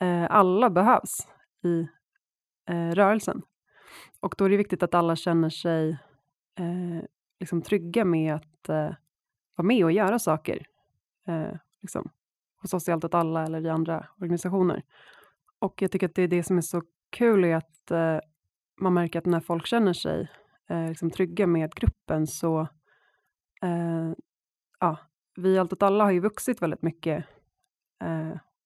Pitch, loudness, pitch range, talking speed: 170 Hz, -26 LUFS, 160-190 Hz, 160 wpm